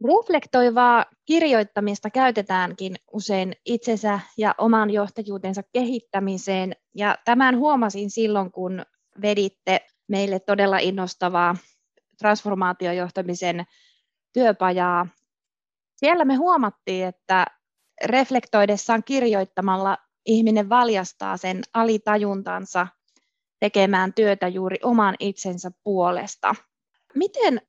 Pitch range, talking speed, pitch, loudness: 185-230 Hz, 80 wpm, 205 Hz, -22 LUFS